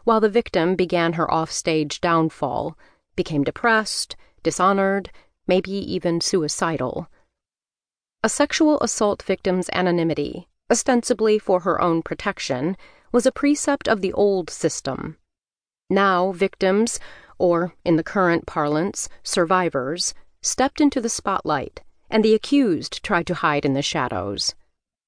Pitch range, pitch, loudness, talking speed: 170-220 Hz, 185 Hz, -21 LUFS, 120 wpm